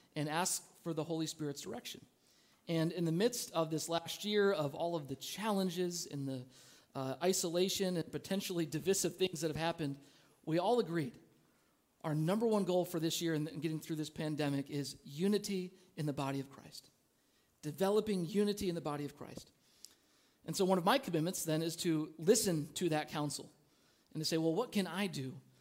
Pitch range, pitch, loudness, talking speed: 150-185 Hz, 165 Hz, -37 LUFS, 190 wpm